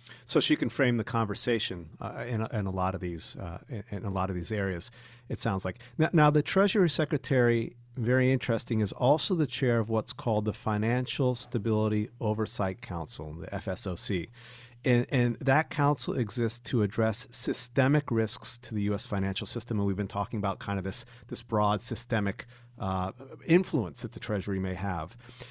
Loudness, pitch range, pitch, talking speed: -29 LUFS, 100-125 Hz, 115 Hz, 180 wpm